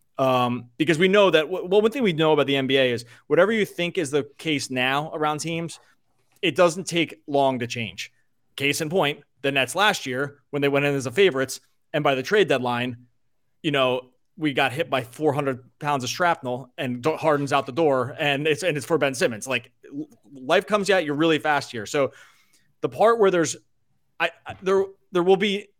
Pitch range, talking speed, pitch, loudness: 130-170 Hz, 210 wpm, 145 Hz, -23 LUFS